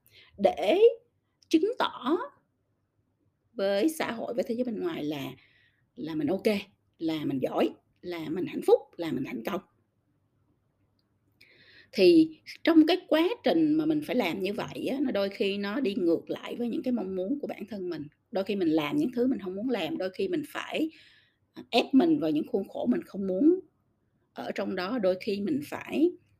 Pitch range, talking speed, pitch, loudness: 195-320 Hz, 190 wpm, 275 Hz, -28 LUFS